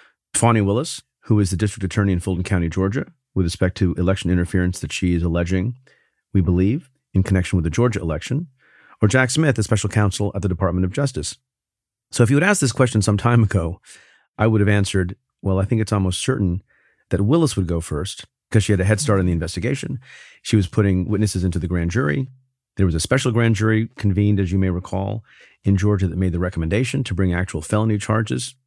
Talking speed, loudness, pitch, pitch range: 215 wpm, -20 LUFS, 100 Hz, 95-120 Hz